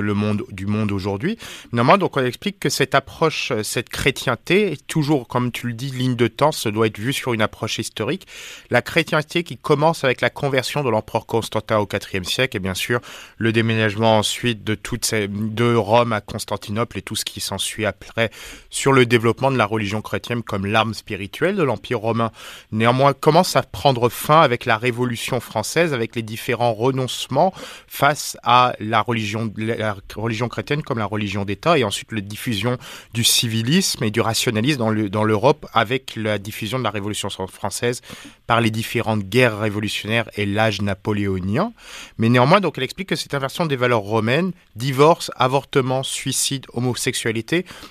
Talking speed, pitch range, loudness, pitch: 180 wpm, 110-135 Hz, -20 LUFS, 115 Hz